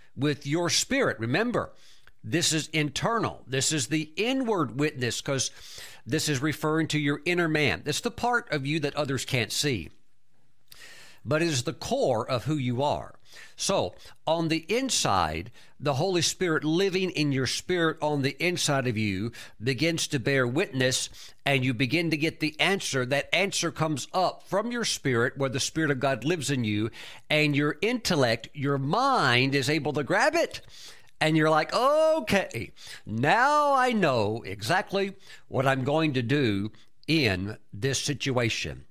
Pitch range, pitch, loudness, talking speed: 130-160 Hz, 150 Hz, -26 LUFS, 160 wpm